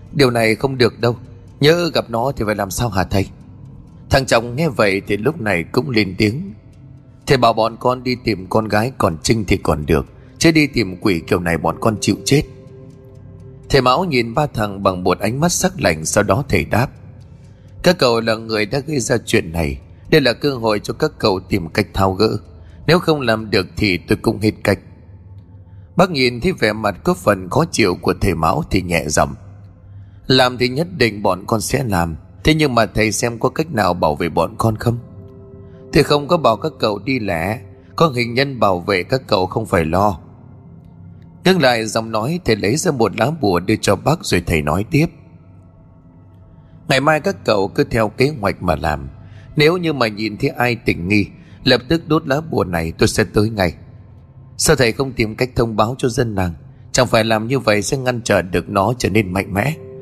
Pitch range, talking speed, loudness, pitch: 95-130 Hz, 215 wpm, -17 LUFS, 110 Hz